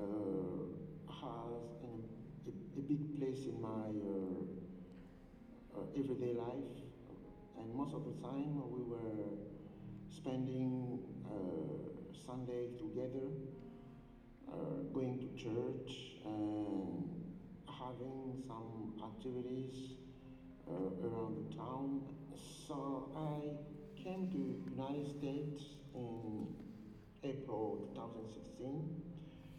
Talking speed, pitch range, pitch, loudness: 95 wpm, 115-145 Hz, 130 Hz, -45 LUFS